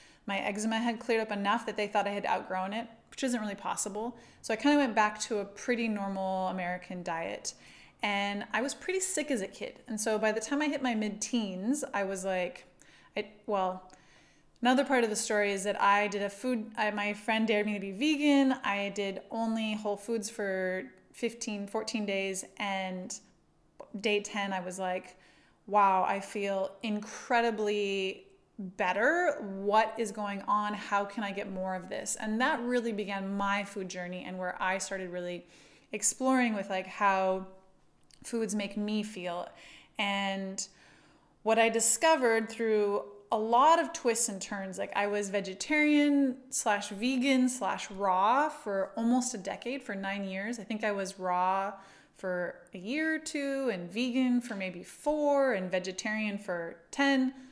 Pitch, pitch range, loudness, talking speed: 210 Hz, 195-235 Hz, -31 LUFS, 175 wpm